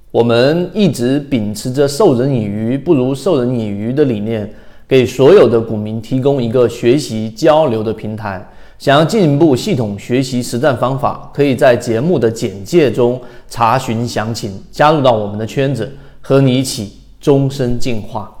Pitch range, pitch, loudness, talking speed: 110-135 Hz, 125 Hz, -14 LUFS, 260 characters per minute